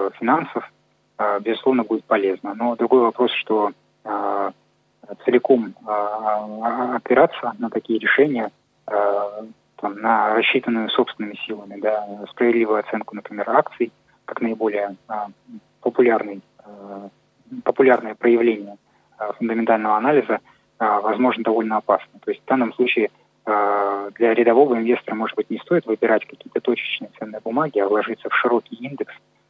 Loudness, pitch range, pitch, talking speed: -21 LUFS, 105-120 Hz, 110 Hz, 105 wpm